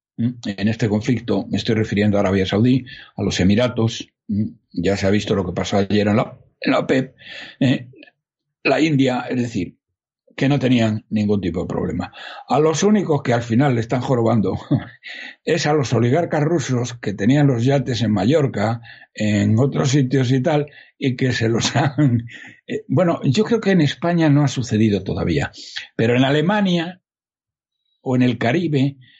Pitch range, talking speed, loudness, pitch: 105-140 Hz, 175 wpm, -19 LUFS, 125 Hz